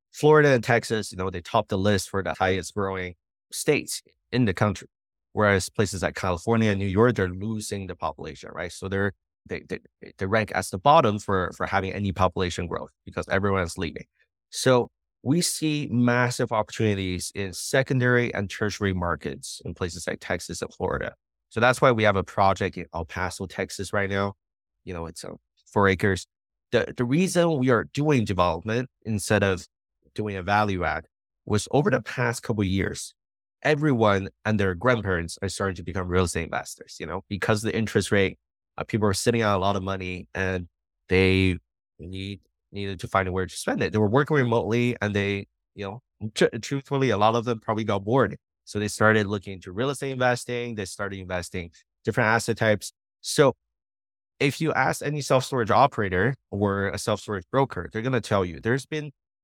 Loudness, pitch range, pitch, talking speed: -25 LUFS, 95-115 Hz, 100 Hz, 190 wpm